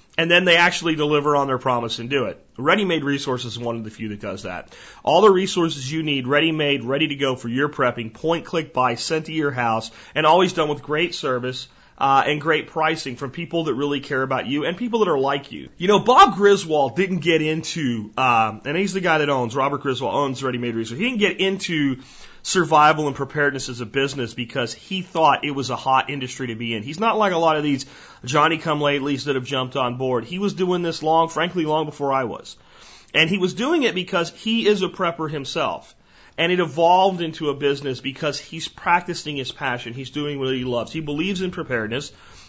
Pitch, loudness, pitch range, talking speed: 150 Hz, -21 LUFS, 130-170 Hz, 225 wpm